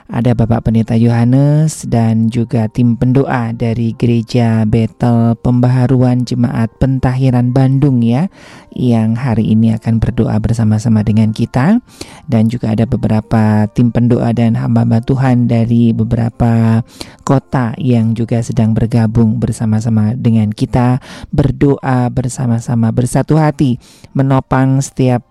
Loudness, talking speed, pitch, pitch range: -13 LUFS, 115 wpm, 120 Hz, 115-130 Hz